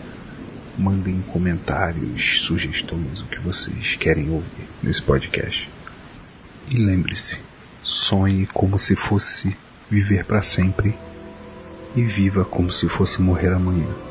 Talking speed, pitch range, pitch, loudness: 110 wpm, 90-100 Hz, 95 Hz, -21 LUFS